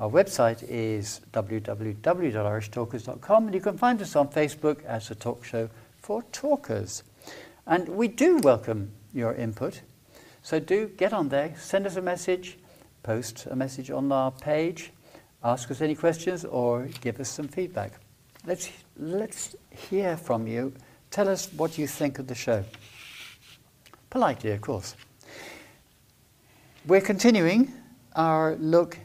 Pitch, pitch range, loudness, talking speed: 145 Hz, 115-180 Hz, -27 LUFS, 140 wpm